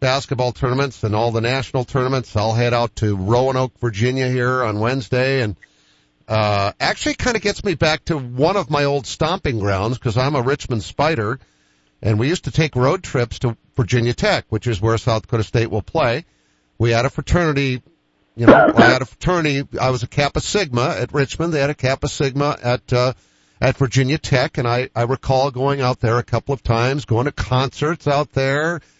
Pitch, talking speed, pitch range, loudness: 125 Hz, 200 wpm, 115-140 Hz, -19 LUFS